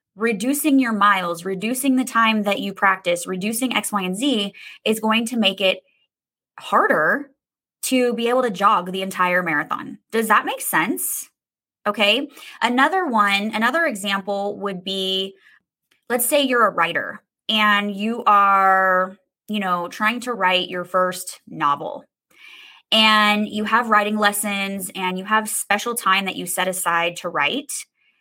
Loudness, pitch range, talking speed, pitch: -19 LUFS, 190-230 Hz, 150 wpm, 205 Hz